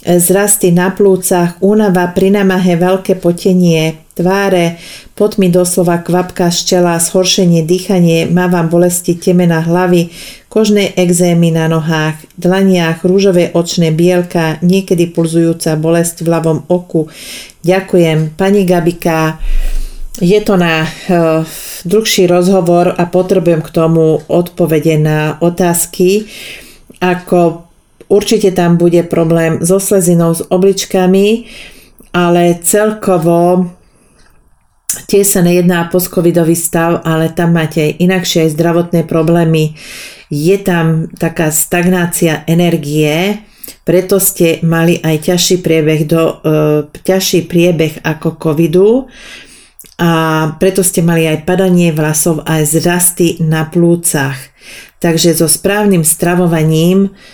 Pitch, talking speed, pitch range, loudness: 175 Hz, 110 wpm, 165-185 Hz, -11 LUFS